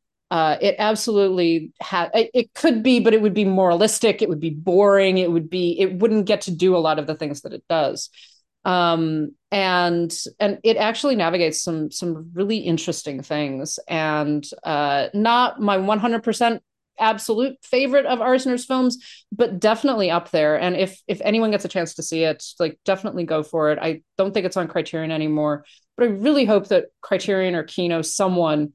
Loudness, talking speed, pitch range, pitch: -20 LUFS, 190 wpm, 160-220 Hz, 185 Hz